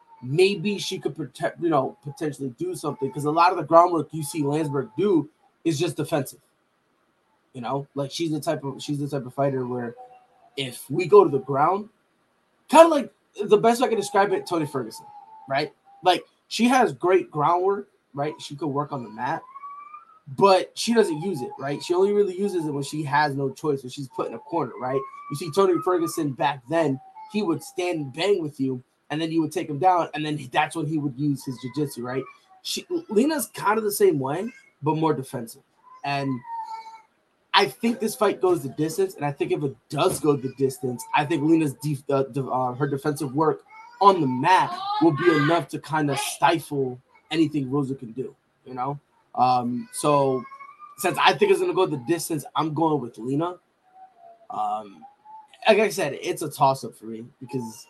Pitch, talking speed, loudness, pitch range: 160 Hz, 205 wpm, -24 LUFS, 140-205 Hz